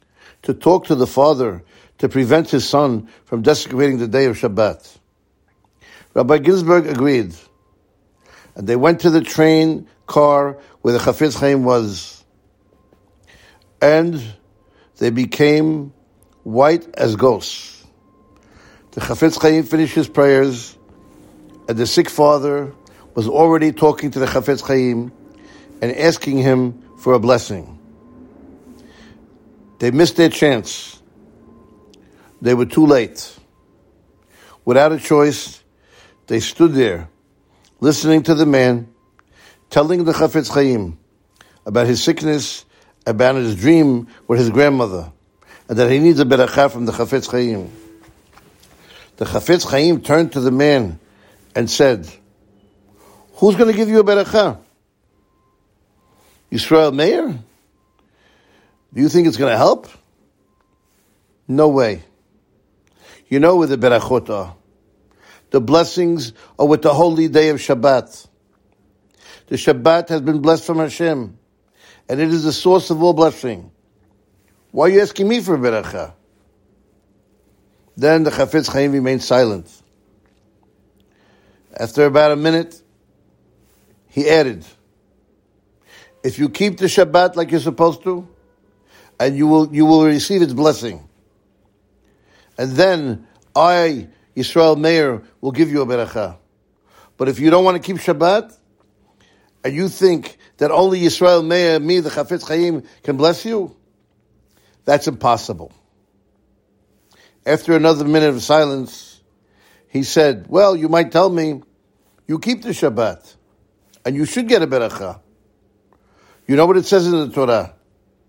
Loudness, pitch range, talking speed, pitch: -15 LUFS, 105-160 Hz, 130 wpm, 135 Hz